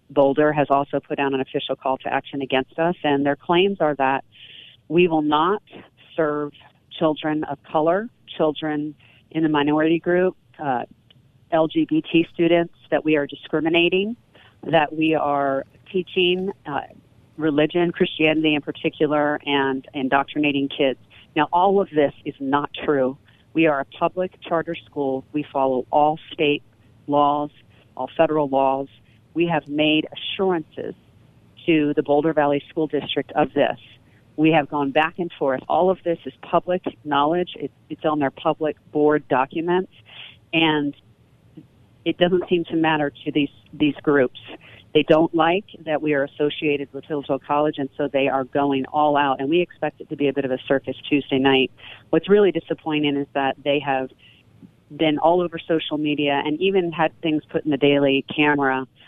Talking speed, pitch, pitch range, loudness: 165 wpm, 150 Hz, 135-160 Hz, -21 LUFS